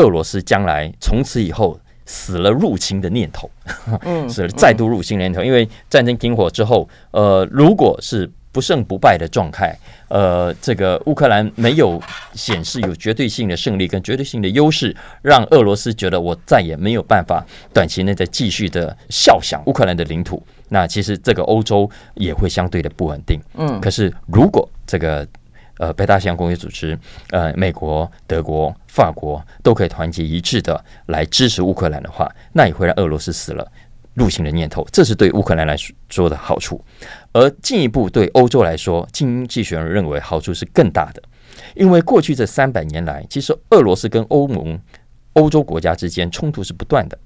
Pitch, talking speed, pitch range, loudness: 95 Hz, 285 characters per minute, 85-115 Hz, -16 LUFS